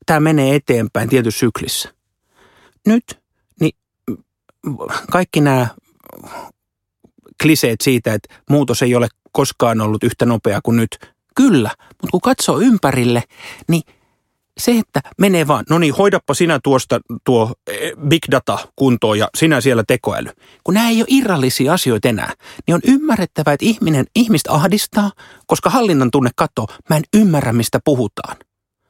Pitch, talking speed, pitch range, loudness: 145 Hz, 140 wpm, 120-180 Hz, -15 LUFS